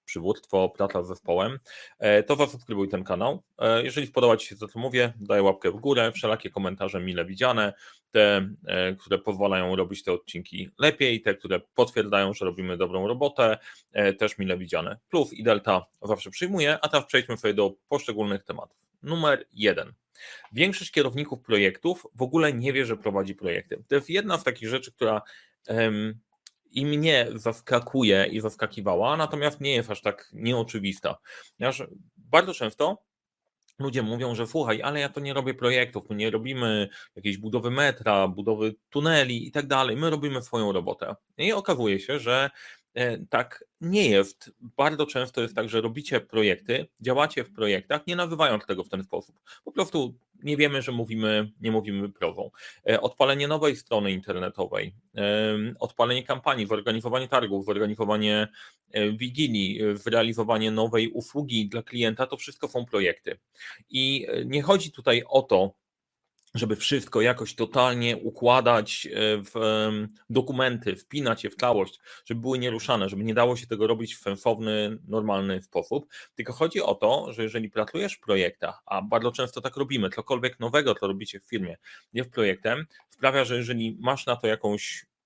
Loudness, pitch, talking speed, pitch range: -26 LUFS, 115 Hz, 155 wpm, 105-135 Hz